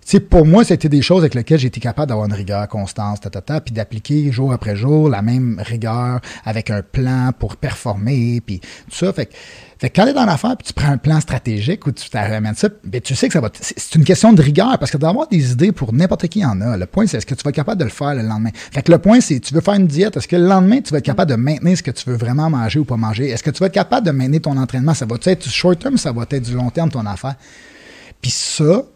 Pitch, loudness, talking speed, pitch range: 140 Hz, -16 LUFS, 300 wpm, 115-165 Hz